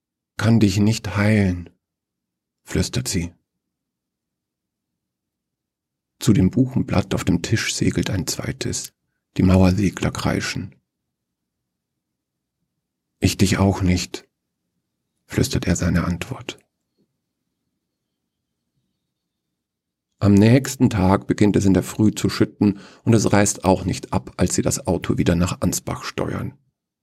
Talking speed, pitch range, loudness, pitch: 110 wpm, 85-105 Hz, -20 LUFS, 95 Hz